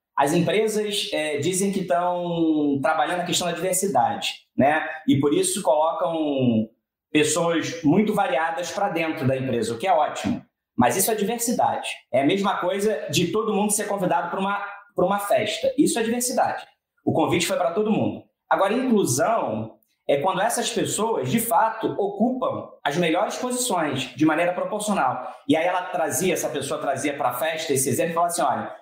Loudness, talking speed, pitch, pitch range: -23 LUFS, 175 wpm, 180 Hz, 160-210 Hz